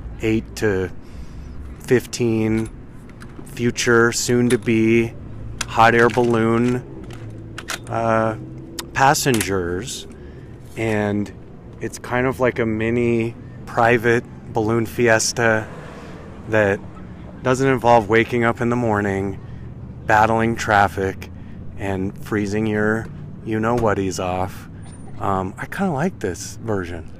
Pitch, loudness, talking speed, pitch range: 110 Hz, -20 LUFS, 100 wpm, 100-120 Hz